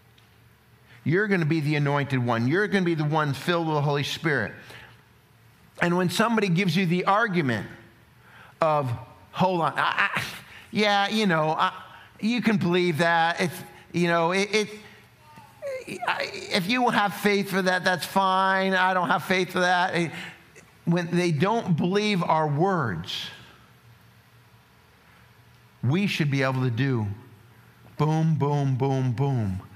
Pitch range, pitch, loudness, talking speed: 135-190 Hz, 170 Hz, -24 LUFS, 150 wpm